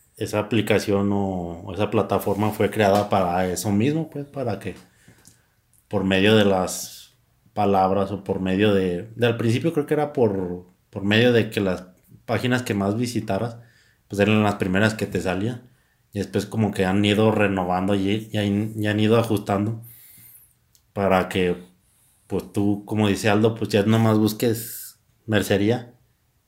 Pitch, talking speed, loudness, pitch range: 105 Hz, 165 wpm, -22 LUFS, 100-115 Hz